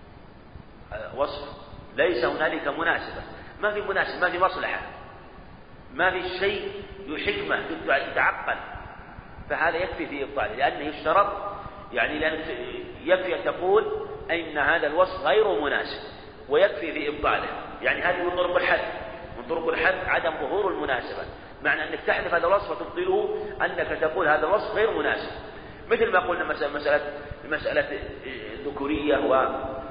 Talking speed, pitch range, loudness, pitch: 125 wpm, 145-200 Hz, -25 LUFS, 180 Hz